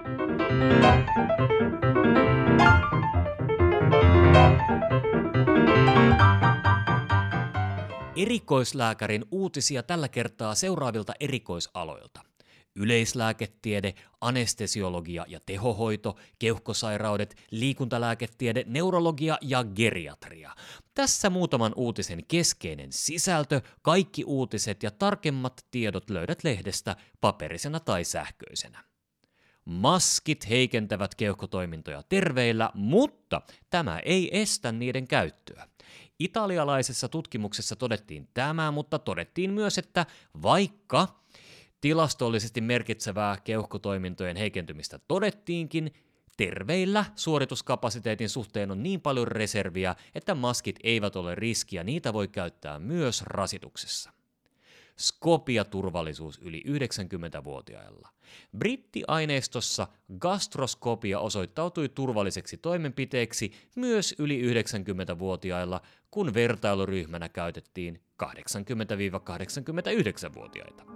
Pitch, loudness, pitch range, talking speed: 115 Hz, -27 LUFS, 100-145 Hz, 75 wpm